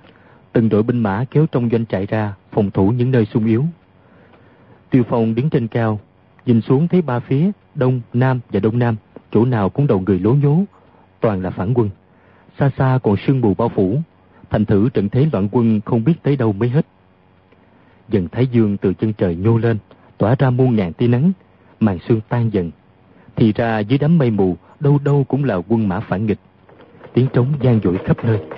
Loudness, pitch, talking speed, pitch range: -17 LUFS, 115 Hz, 205 wpm, 100-130 Hz